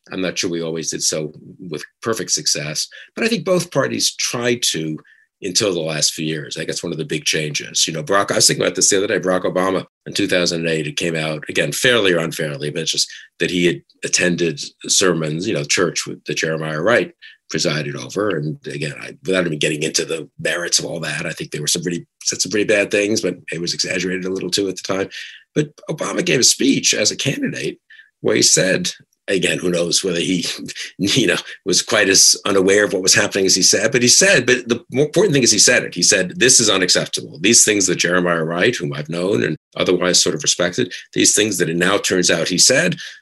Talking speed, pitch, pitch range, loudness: 235 wpm, 90 Hz, 80-100 Hz, -16 LUFS